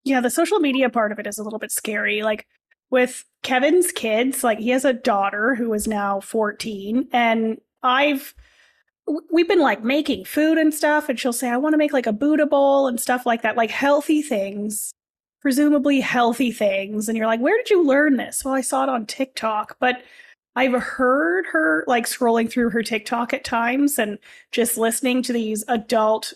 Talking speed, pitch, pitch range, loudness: 195 wpm, 250 Hz, 225-275 Hz, -20 LUFS